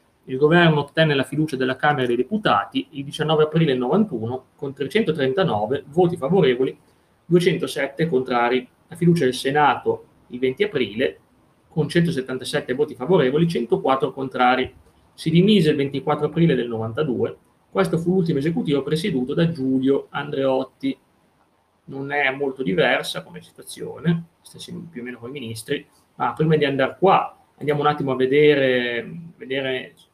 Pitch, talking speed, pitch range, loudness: 145 Hz, 145 wpm, 130-170 Hz, -21 LUFS